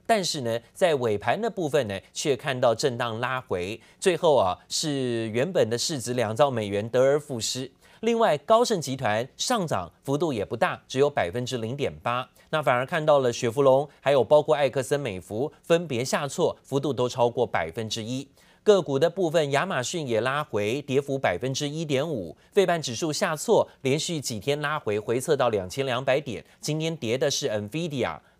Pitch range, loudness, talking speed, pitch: 120-155 Hz, -25 LUFS, 285 characters per minute, 135 Hz